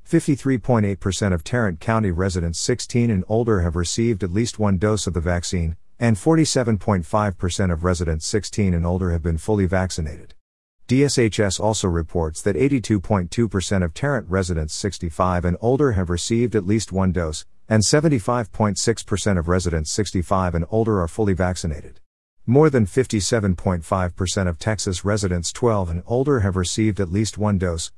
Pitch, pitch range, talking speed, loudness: 100 Hz, 90-110 Hz, 150 wpm, -21 LUFS